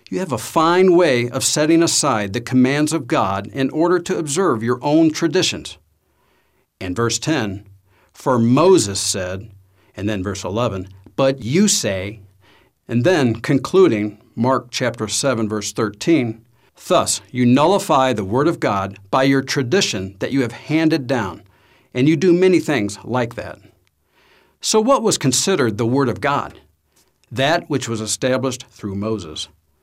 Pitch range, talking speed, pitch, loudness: 100-145 Hz, 155 wpm, 120 Hz, -18 LUFS